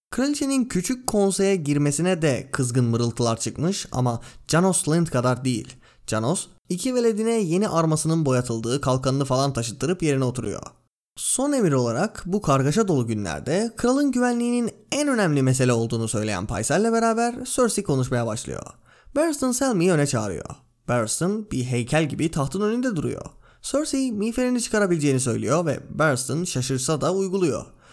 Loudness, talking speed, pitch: -23 LUFS, 135 wpm, 155 Hz